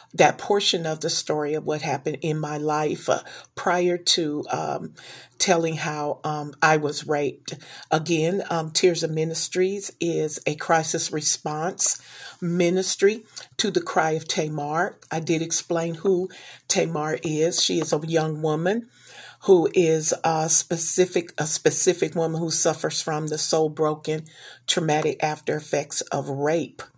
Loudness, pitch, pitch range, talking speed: -23 LUFS, 160 Hz, 155-175 Hz, 145 wpm